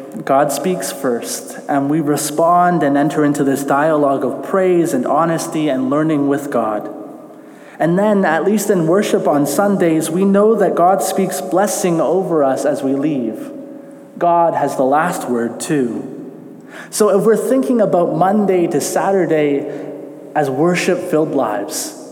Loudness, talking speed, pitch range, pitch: -15 LUFS, 150 wpm, 145-195 Hz, 170 Hz